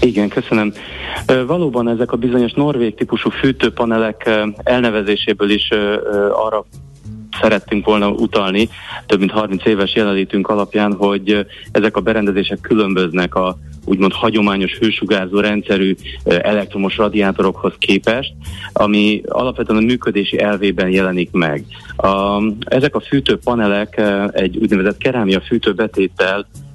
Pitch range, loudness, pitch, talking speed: 100-115 Hz, -16 LUFS, 105 Hz, 110 wpm